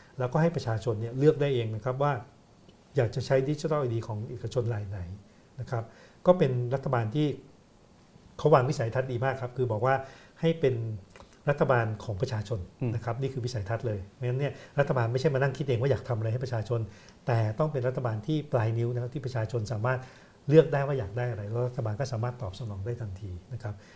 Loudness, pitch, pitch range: -29 LUFS, 125 Hz, 115-135 Hz